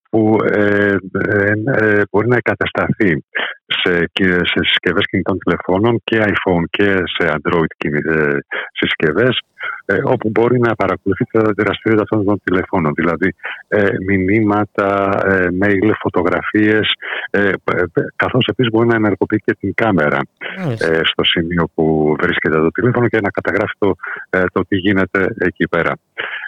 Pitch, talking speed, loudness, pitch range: 100 Hz, 140 wpm, -15 LUFS, 90-110 Hz